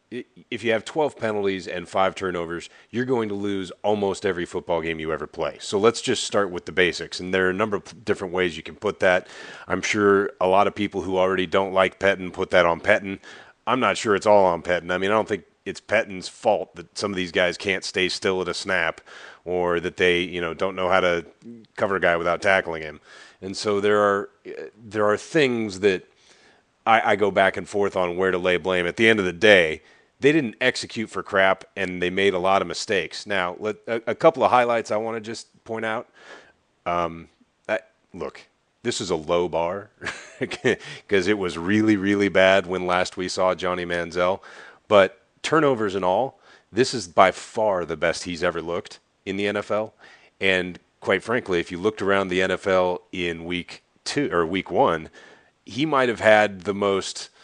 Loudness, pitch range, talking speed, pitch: -23 LUFS, 90-105 Hz, 210 wpm, 95 Hz